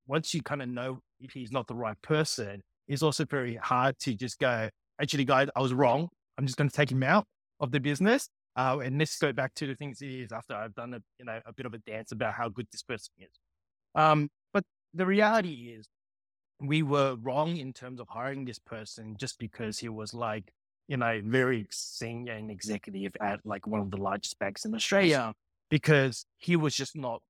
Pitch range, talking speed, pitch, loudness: 110-145 Hz, 215 wpm, 125 Hz, -30 LUFS